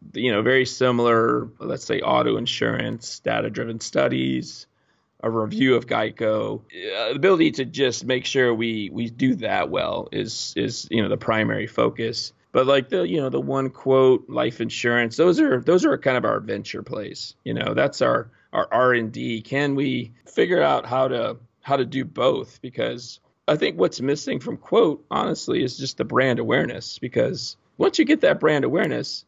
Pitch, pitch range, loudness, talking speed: 125 Hz, 115-135 Hz, -22 LUFS, 185 wpm